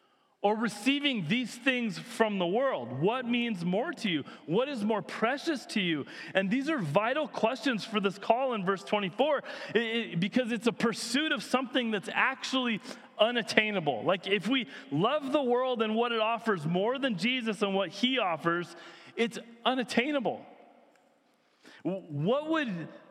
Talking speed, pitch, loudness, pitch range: 155 wpm, 230 Hz, -30 LUFS, 205-255 Hz